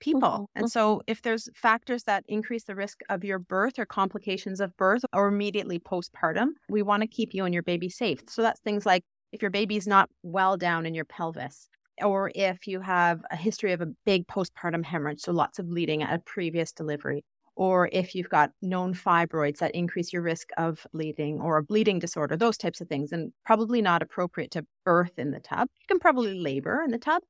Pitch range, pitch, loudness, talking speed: 170-215 Hz, 190 Hz, -27 LUFS, 215 wpm